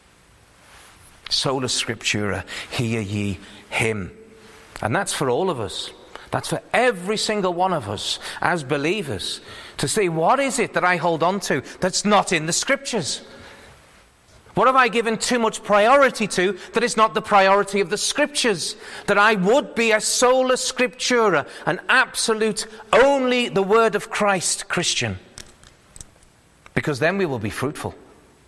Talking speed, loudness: 150 wpm, -20 LUFS